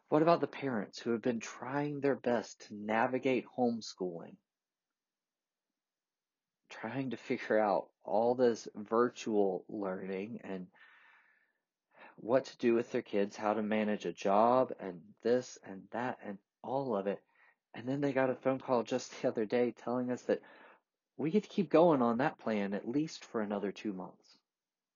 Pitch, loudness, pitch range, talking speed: 120 Hz, -34 LUFS, 105-130 Hz, 165 wpm